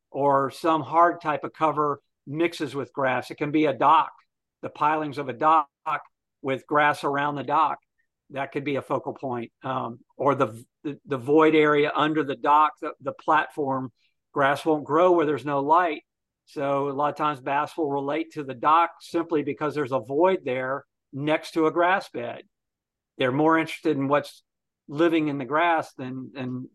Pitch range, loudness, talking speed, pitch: 140-155 Hz, -24 LUFS, 185 wpm, 150 Hz